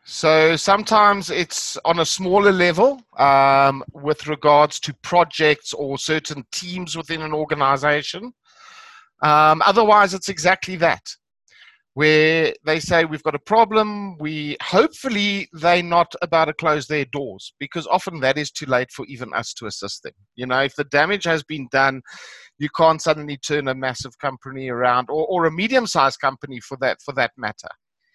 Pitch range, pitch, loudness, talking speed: 145-185 Hz, 155 Hz, -19 LUFS, 165 wpm